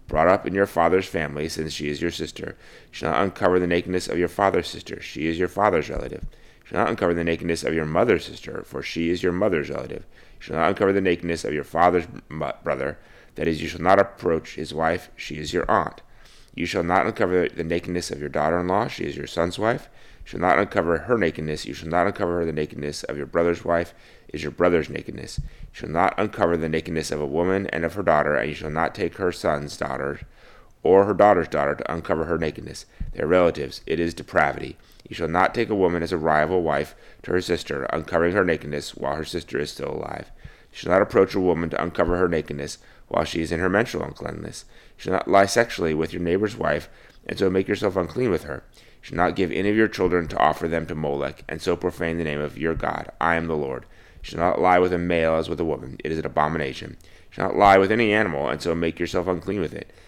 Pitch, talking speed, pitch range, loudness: 85 Hz, 245 wpm, 80-90 Hz, -23 LUFS